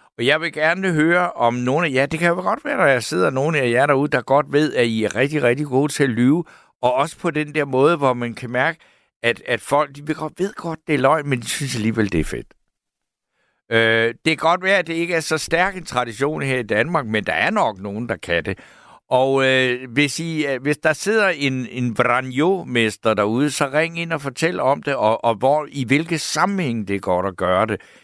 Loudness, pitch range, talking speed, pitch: -19 LUFS, 120-160 Hz, 250 wpm, 140 Hz